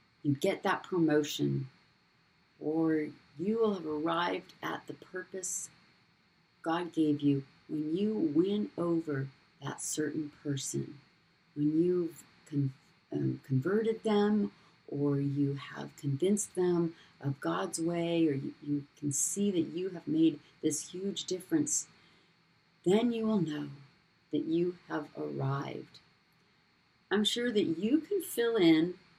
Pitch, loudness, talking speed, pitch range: 165 Hz, -33 LUFS, 130 wpm, 150-190 Hz